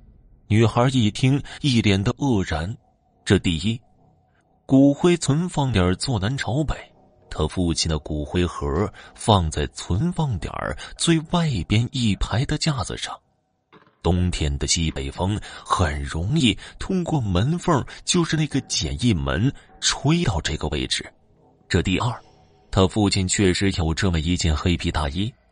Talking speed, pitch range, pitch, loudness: 200 characters per minute, 85-135 Hz, 100 Hz, -22 LUFS